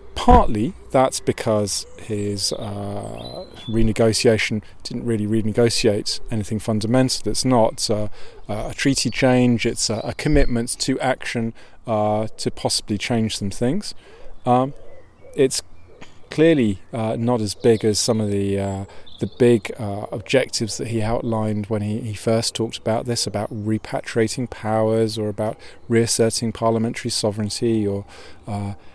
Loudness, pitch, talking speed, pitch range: -21 LUFS, 110 Hz, 135 wpm, 105-120 Hz